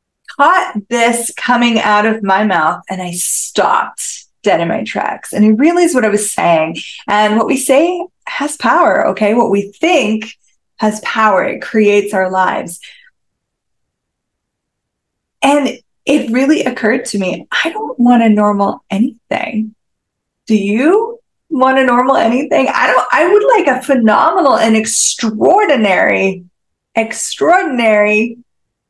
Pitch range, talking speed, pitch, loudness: 210-280 Hz, 135 wpm, 230 Hz, -12 LUFS